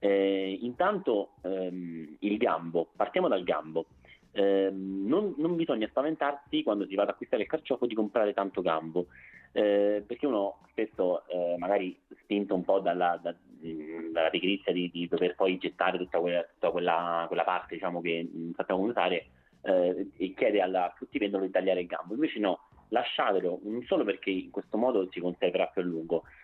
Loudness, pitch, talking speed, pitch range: -30 LUFS, 95 Hz, 175 wpm, 85-100 Hz